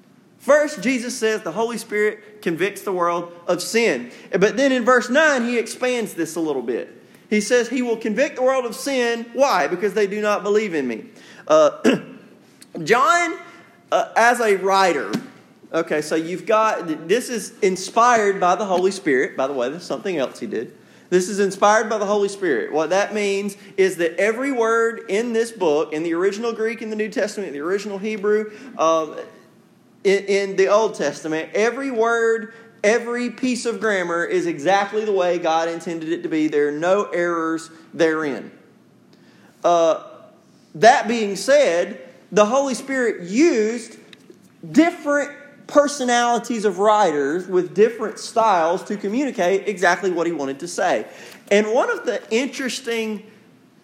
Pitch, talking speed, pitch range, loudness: 215 Hz, 165 wpm, 185-240 Hz, -20 LUFS